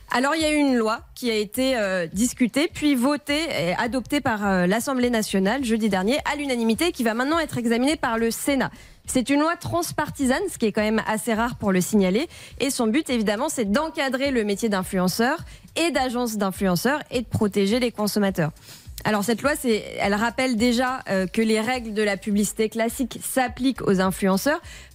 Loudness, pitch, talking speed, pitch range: -23 LUFS, 235 Hz, 195 wpm, 210-270 Hz